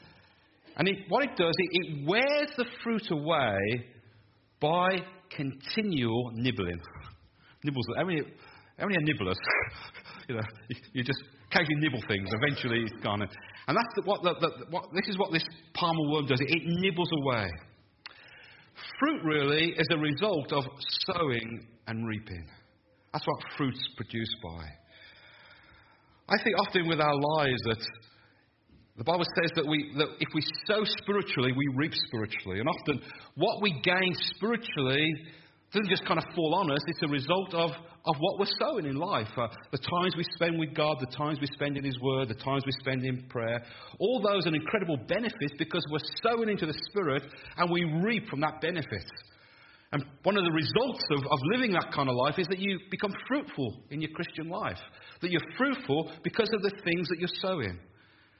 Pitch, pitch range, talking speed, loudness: 150 Hz, 125-175 Hz, 180 wpm, -30 LUFS